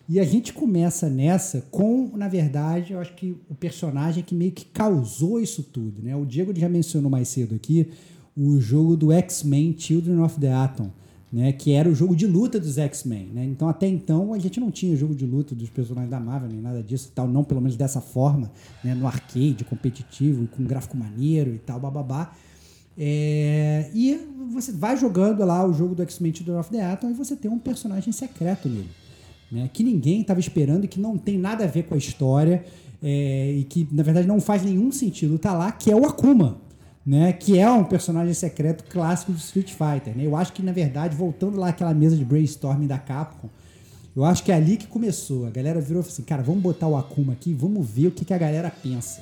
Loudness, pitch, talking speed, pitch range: -23 LUFS, 160 Hz, 220 wpm, 135-180 Hz